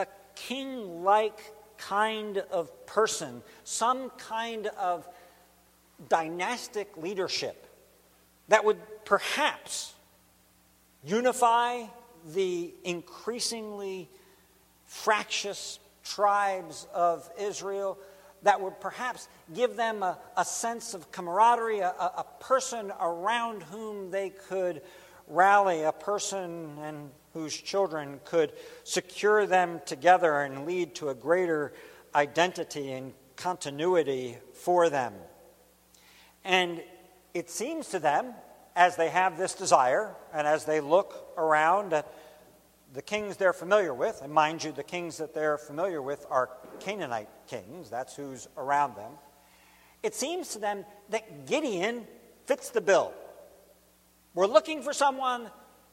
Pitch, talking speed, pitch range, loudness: 185 Hz, 115 wpm, 155-215 Hz, -29 LUFS